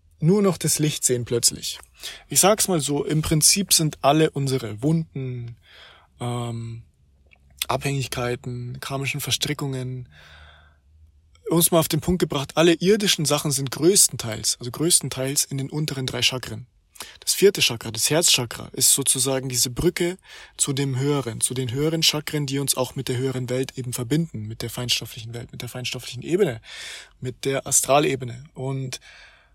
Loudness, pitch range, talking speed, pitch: -21 LUFS, 120-150 Hz, 155 wpm, 135 Hz